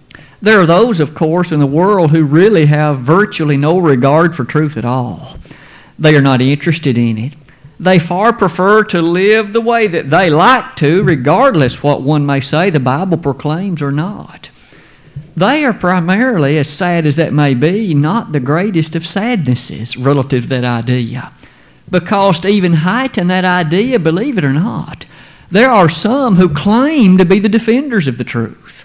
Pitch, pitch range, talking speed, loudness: 165 Hz, 145-195 Hz, 175 wpm, -11 LUFS